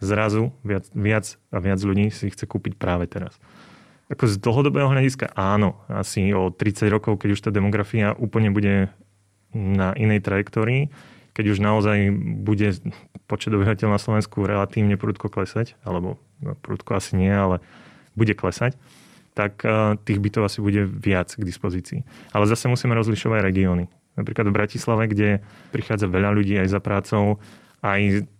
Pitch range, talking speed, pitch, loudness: 100-110 Hz, 150 wpm, 105 Hz, -22 LUFS